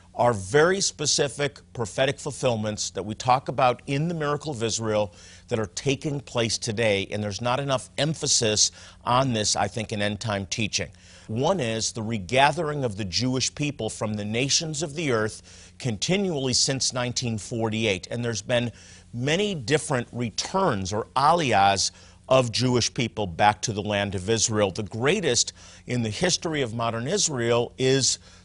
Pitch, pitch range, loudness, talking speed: 115 Hz, 105-135 Hz, -24 LUFS, 160 wpm